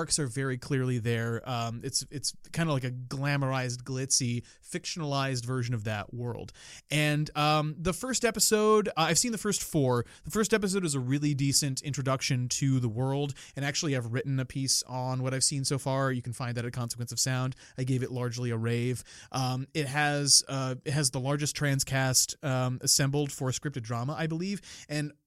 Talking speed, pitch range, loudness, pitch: 200 wpm, 125-150 Hz, -29 LUFS, 135 Hz